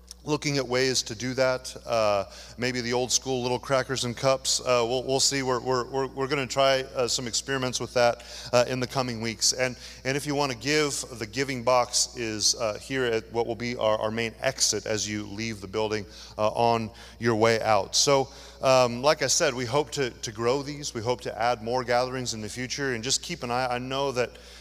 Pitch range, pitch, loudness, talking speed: 115-135 Hz, 125 Hz, -26 LUFS, 230 wpm